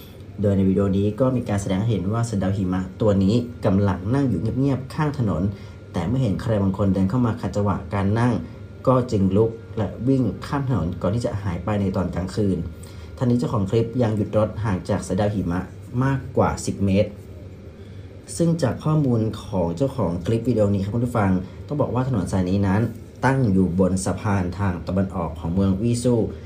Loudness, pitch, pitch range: -22 LUFS, 100 Hz, 95-115 Hz